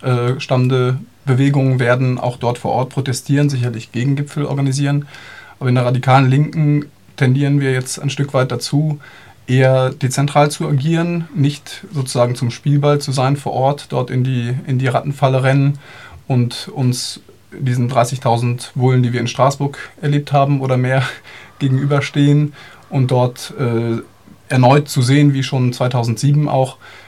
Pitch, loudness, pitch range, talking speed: 130 Hz, -16 LUFS, 125-145 Hz, 145 wpm